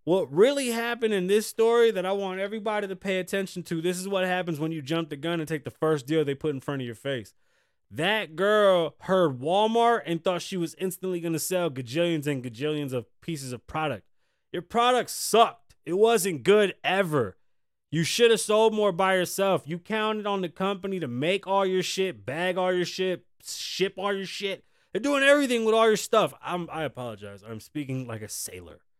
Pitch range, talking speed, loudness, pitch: 155-200 Hz, 210 wpm, -26 LUFS, 185 Hz